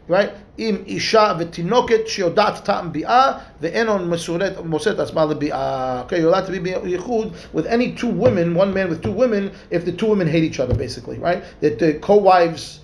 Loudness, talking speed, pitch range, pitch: -19 LUFS, 140 wpm, 165-210 Hz, 180 Hz